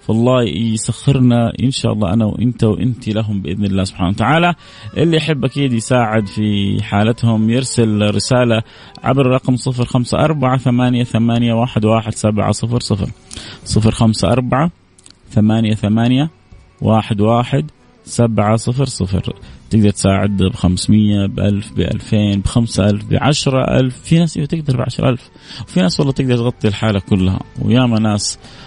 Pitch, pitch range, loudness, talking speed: 115 Hz, 105-125 Hz, -15 LUFS, 115 wpm